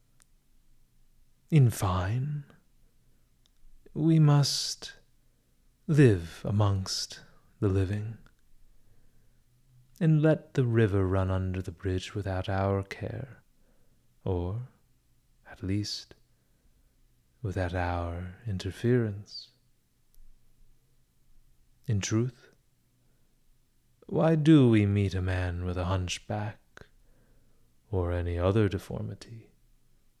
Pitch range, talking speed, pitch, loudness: 95-125 Hz, 80 wpm, 105 Hz, -28 LUFS